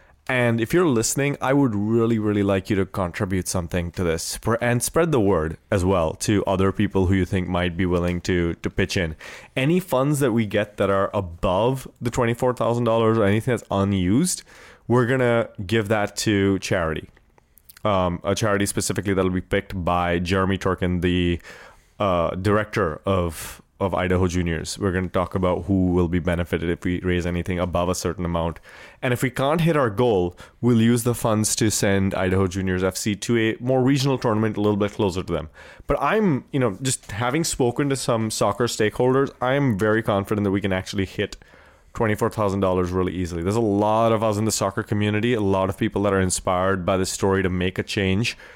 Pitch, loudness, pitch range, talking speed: 100 Hz, -22 LUFS, 90-115 Hz, 205 wpm